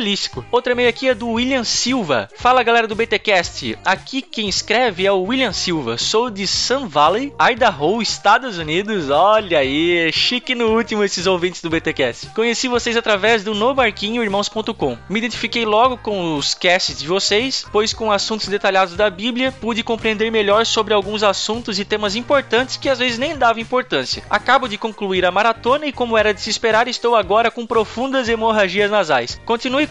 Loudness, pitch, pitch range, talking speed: -17 LUFS, 220 Hz, 200-240 Hz, 175 wpm